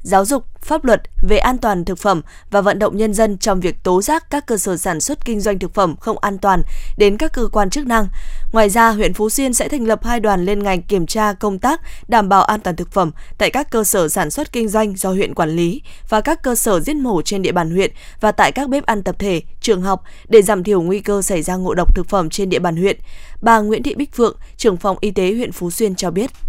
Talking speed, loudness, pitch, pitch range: 265 wpm, -17 LUFS, 205 Hz, 190-230 Hz